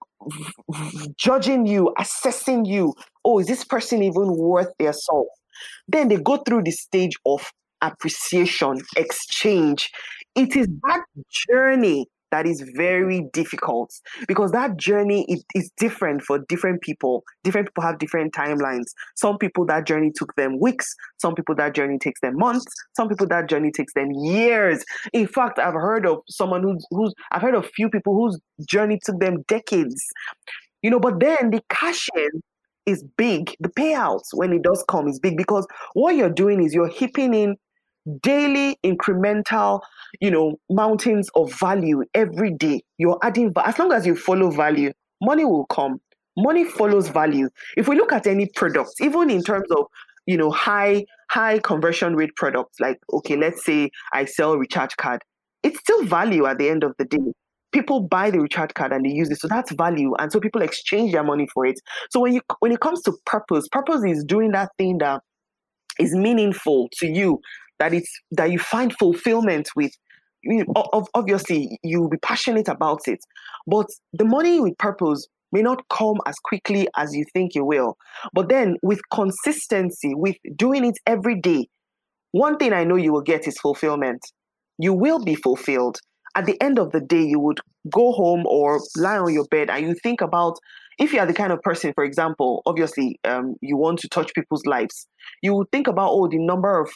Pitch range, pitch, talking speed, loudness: 155-225 Hz, 190 Hz, 185 wpm, -21 LUFS